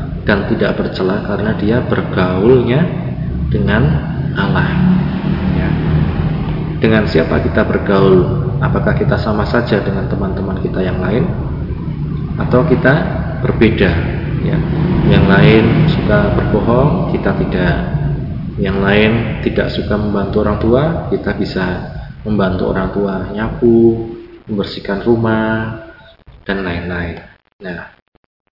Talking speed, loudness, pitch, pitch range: 105 wpm, -14 LUFS, 110 Hz, 95-130 Hz